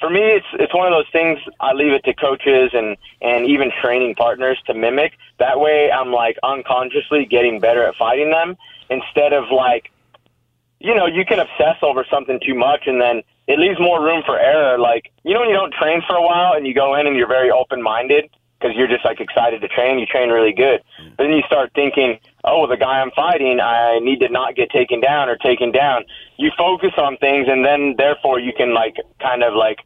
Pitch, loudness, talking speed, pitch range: 135 Hz, -16 LUFS, 225 wpm, 120-155 Hz